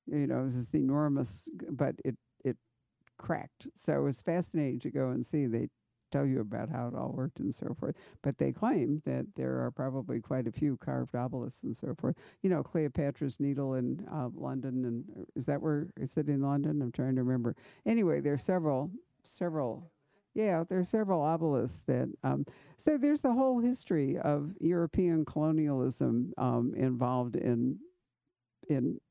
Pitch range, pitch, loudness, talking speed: 125-165 Hz, 145 Hz, -33 LUFS, 180 wpm